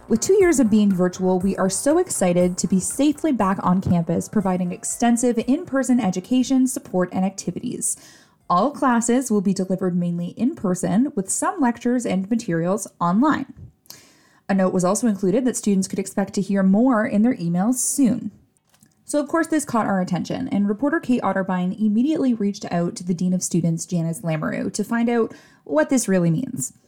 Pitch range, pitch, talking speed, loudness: 185-250 Hz, 210 Hz, 185 wpm, -21 LUFS